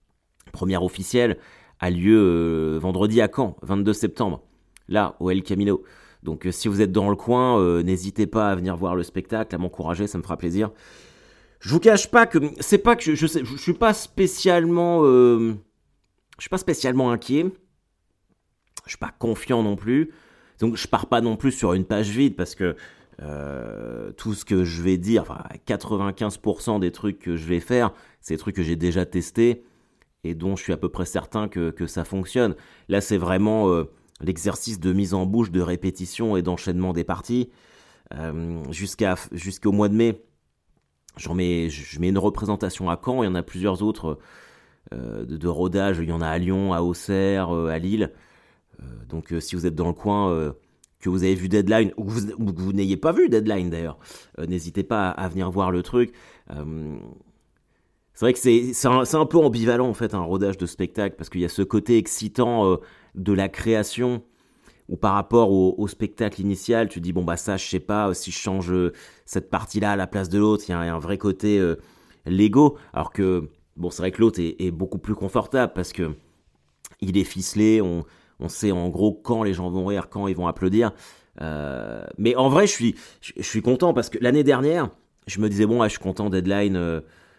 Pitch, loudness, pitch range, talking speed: 100 Hz, -23 LUFS, 90-115 Hz, 210 wpm